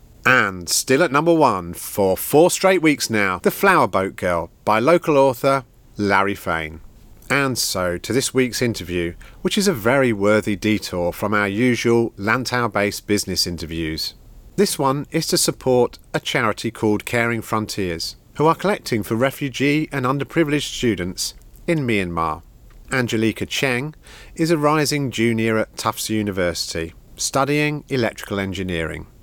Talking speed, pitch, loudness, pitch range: 140 wpm, 115 Hz, -20 LUFS, 100-140 Hz